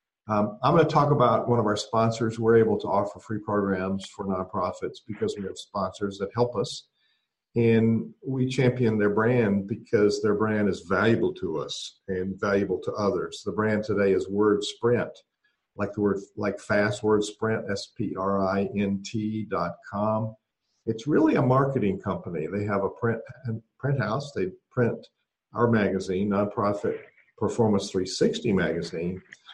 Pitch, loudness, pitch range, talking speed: 105 Hz, -26 LUFS, 100-115 Hz, 165 wpm